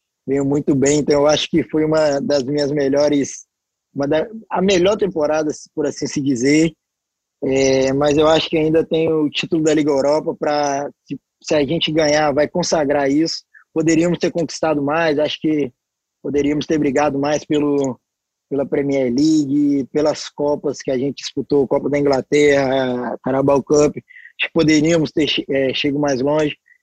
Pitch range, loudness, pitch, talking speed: 140-160 Hz, -17 LUFS, 150 Hz, 160 wpm